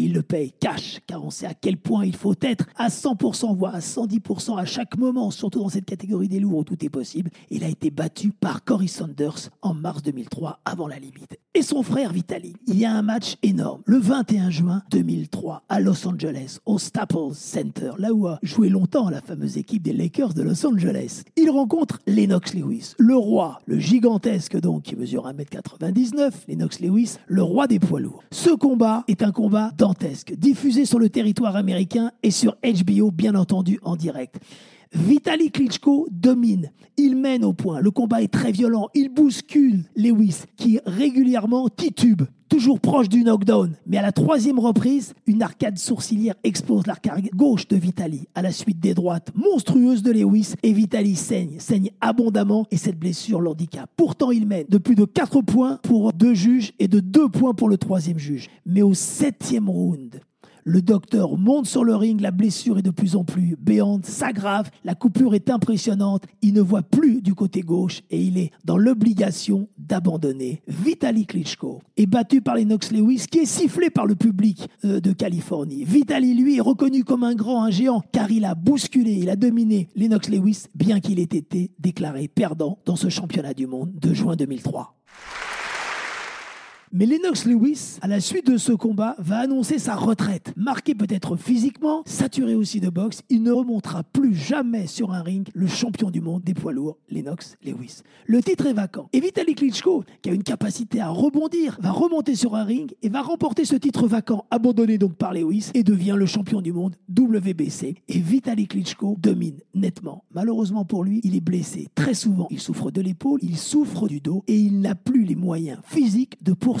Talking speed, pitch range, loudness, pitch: 190 wpm, 185-245 Hz, -21 LUFS, 210 Hz